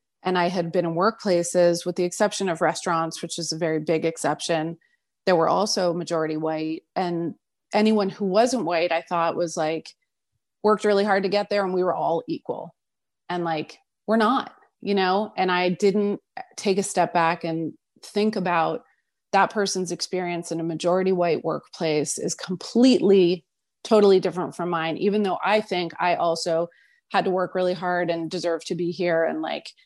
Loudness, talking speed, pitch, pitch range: -23 LUFS, 180 wpm, 180 Hz, 165-200 Hz